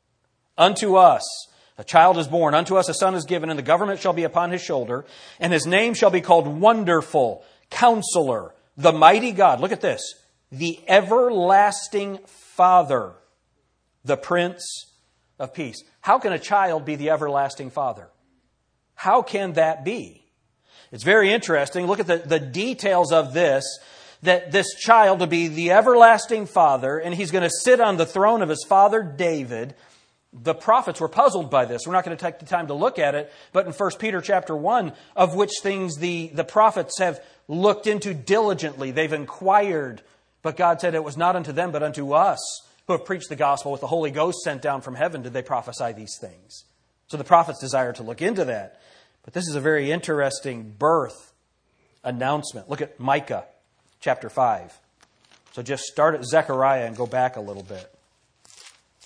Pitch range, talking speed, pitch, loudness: 145-195 Hz, 180 wpm, 170 Hz, -20 LUFS